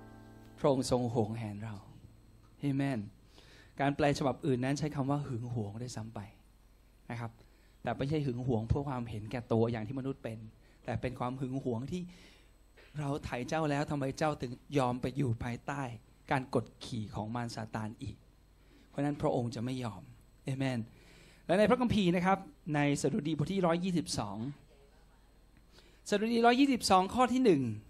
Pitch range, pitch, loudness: 115-145 Hz, 130 Hz, -34 LUFS